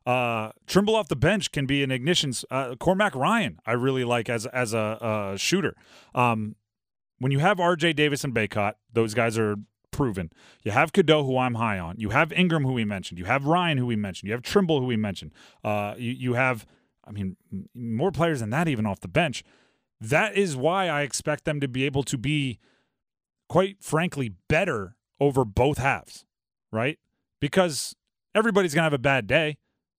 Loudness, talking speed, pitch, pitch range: -25 LUFS, 195 wpm, 130 Hz, 110-155 Hz